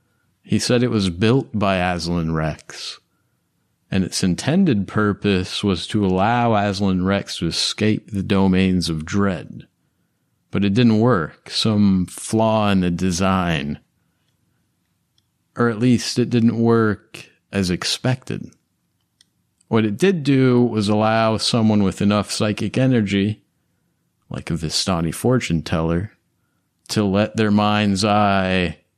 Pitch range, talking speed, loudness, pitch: 95-110 Hz, 125 wpm, -19 LUFS, 100 Hz